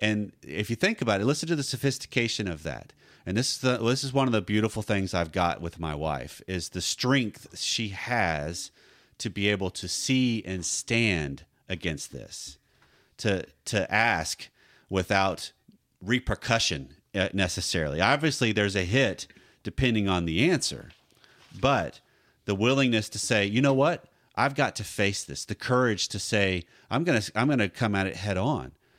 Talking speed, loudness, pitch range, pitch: 170 wpm, -27 LUFS, 90-120 Hz, 105 Hz